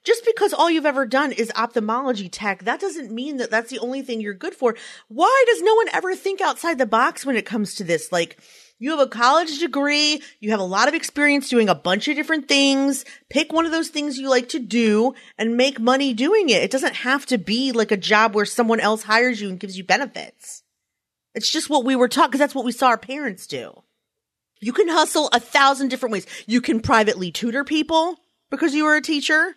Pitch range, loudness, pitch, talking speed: 225-305 Hz, -20 LUFS, 265 Hz, 230 wpm